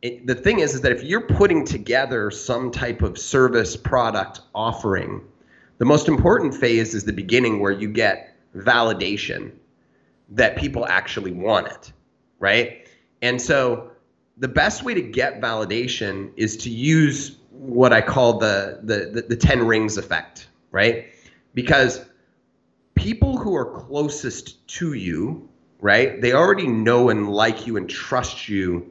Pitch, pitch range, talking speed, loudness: 115 Hz, 105-125 Hz, 150 wpm, -20 LUFS